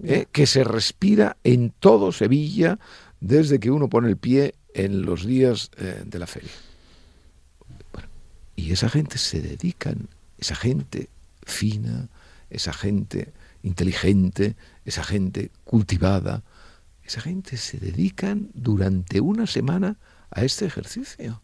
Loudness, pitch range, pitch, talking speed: -23 LUFS, 95-135 Hz, 105 Hz, 125 wpm